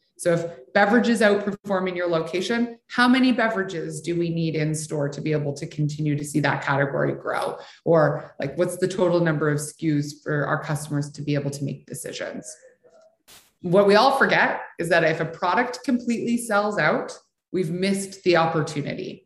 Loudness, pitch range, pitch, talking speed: -23 LUFS, 150-205 Hz, 170 Hz, 180 wpm